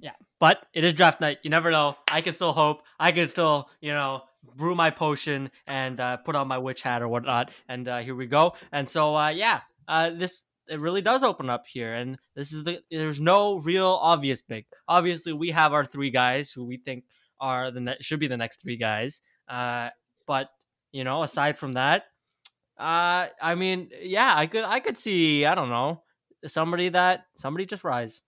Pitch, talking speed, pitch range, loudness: 150 Hz, 205 wpm, 130-170 Hz, -25 LUFS